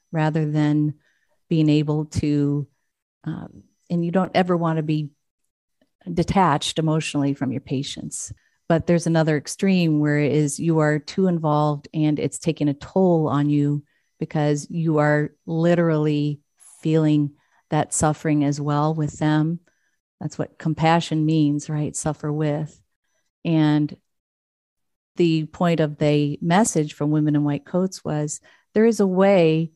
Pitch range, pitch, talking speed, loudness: 150-165 Hz, 155 Hz, 140 wpm, -21 LUFS